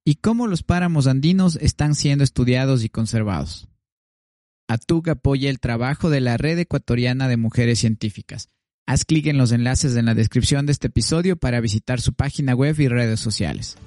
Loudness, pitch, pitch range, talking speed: -20 LUFS, 125 Hz, 115-145 Hz, 175 wpm